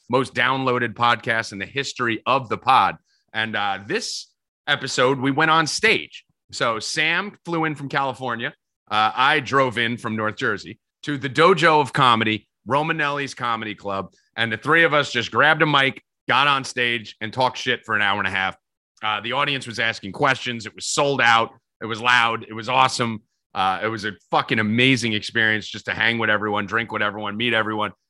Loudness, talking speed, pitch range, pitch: -20 LUFS, 195 wpm, 110-135 Hz, 120 Hz